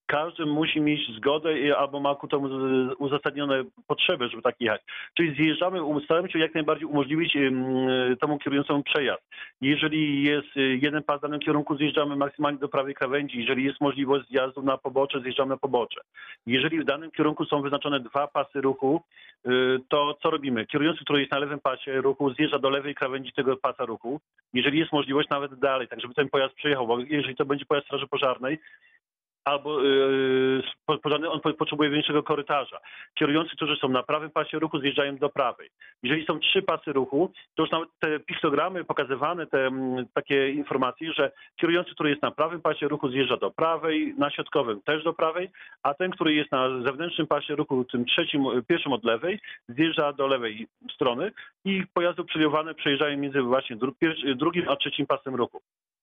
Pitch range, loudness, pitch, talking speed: 135-155 Hz, -26 LUFS, 145 Hz, 175 wpm